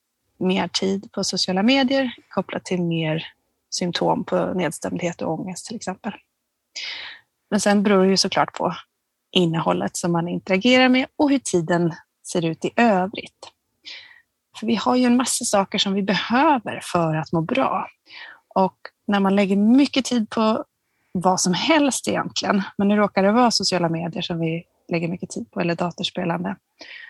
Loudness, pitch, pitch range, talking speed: -21 LUFS, 195 Hz, 180-235 Hz, 165 wpm